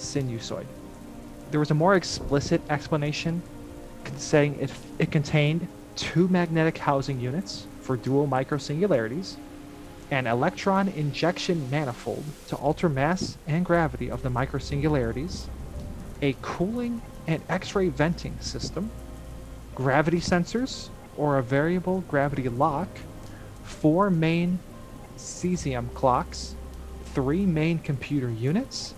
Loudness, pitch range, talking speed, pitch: -26 LUFS, 130-170 Hz, 110 wpm, 150 Hz